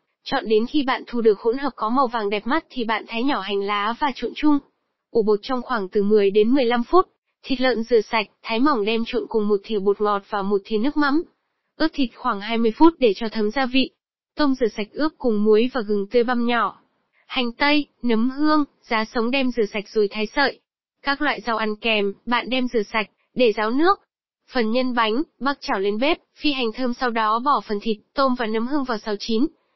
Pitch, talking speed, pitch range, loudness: 235 Hz, 235 wpm, 215-270 Hz, -22 LUFS